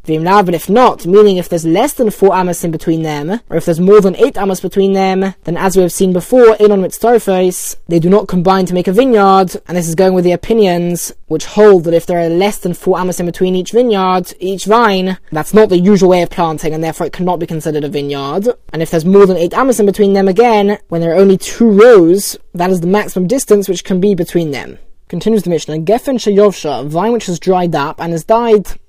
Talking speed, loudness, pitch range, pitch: 245 wpm, -11 LUFS, 170-205 Hz, 185 Hz